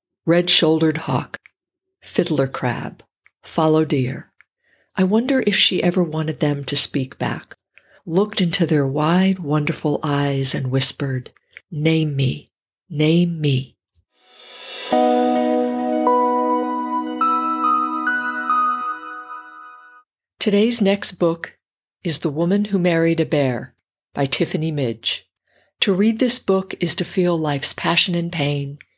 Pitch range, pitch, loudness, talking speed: 140-200 Hz, 165 Hz, -19 LUFS, 110 wpm